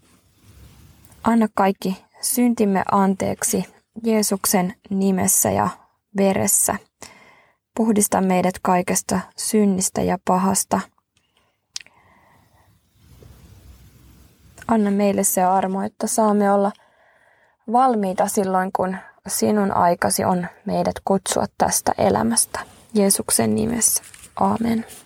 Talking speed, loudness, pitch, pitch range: 80 wpm, -20 LUFS, 200 Hz, 185-220 Hz